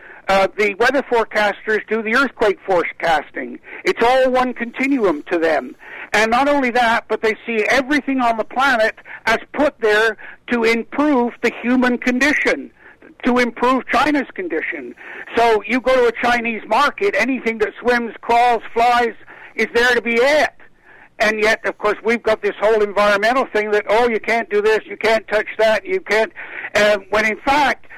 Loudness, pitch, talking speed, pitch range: -17 LUFS, 235 Hz, 170 wpm, 215-260 Hz